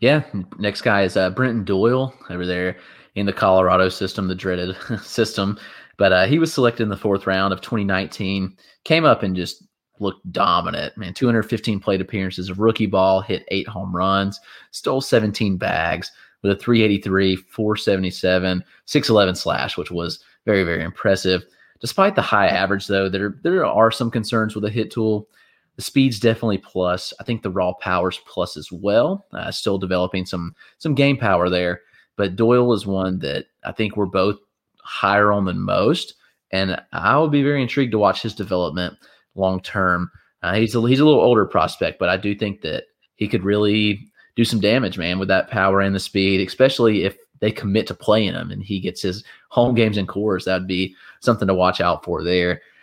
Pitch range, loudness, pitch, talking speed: 95-110 Hz, -20 LUFS, 100 Hz, 185 wpm